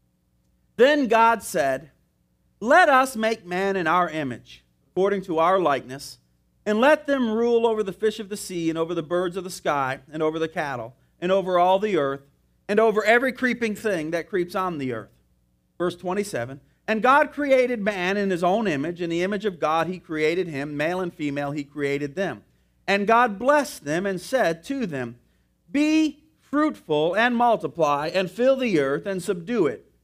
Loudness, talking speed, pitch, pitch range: -23 LUFS, 185 wpm, 180 Hz, 145-220 Hz